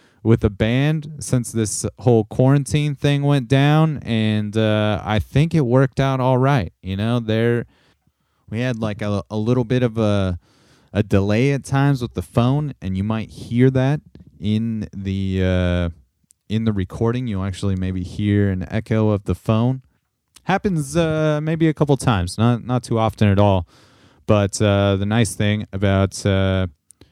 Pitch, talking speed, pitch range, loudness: 110 Hz, 170 wpm, 100-130 Hz, -20 LUFS